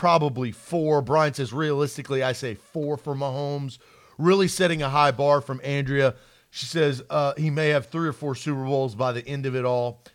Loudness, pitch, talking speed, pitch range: -24 LUFS, 140 Hz, 200 wpm, 130-150 Hz